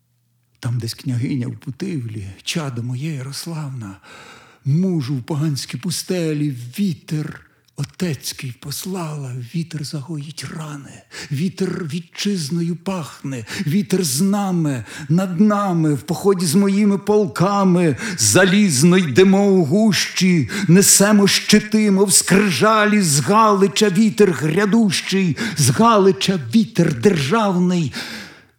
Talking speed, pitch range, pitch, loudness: 95 wpm, 145-195 Hz, 175 Hz, -17 LUFS